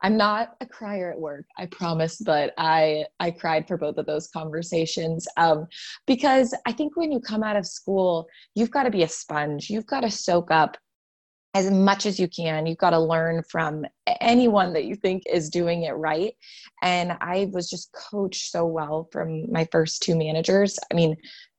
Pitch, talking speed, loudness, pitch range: 175 Hz, 195 wpm, -24 LUFS, 160-205 Hz